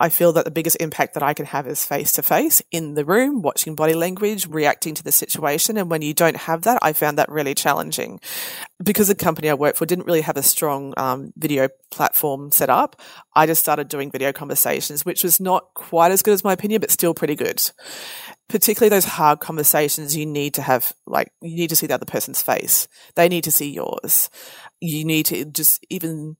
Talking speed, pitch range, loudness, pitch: 220 wpm, 150-175 Hz, -18 LUFS, 160 Hz